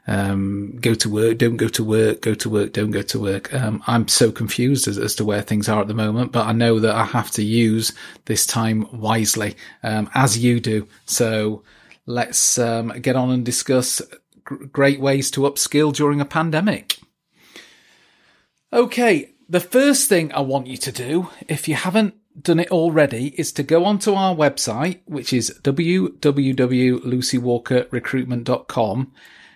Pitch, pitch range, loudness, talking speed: 125 Hz, 110-145 Hz, -19 LUFS, 165 wpm